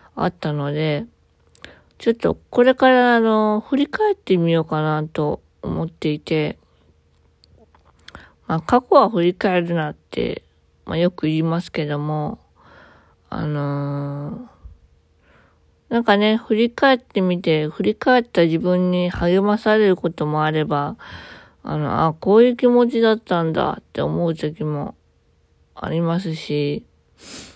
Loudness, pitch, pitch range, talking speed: -19 LUFS, 165 Hz, 150-215 Hz, 250 characters per minute